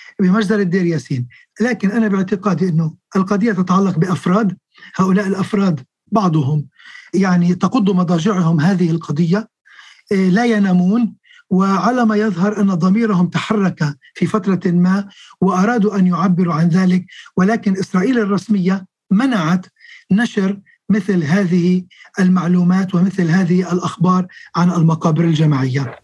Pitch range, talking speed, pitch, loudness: 175-205 Hz, 110 wpm, 185 Hz, -16 LUFS